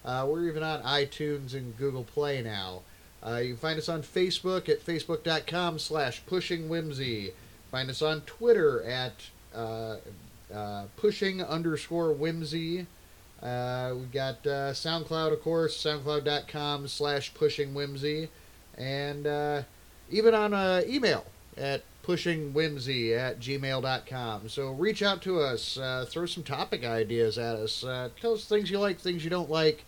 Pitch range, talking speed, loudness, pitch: 125-165 Hz, 145 wpm, -30 LUFS, 145 Hz